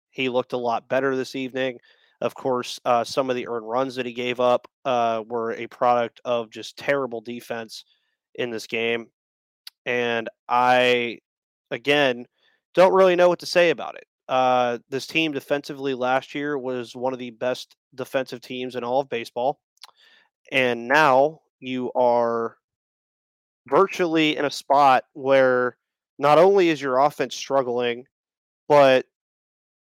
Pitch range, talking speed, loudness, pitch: 120-135 Hz, 150 wpm, -22 LUFS, 125 Hz